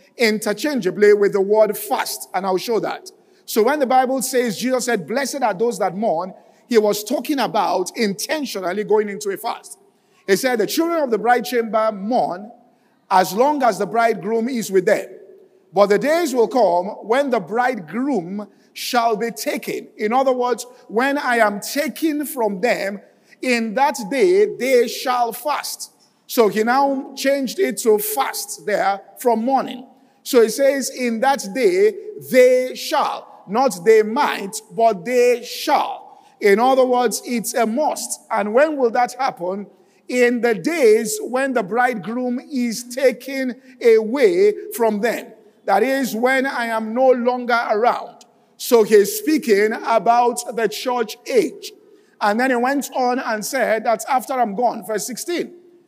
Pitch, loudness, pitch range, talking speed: 245 Hz, -19 LUFS, 220-275 Hz, 160 wpm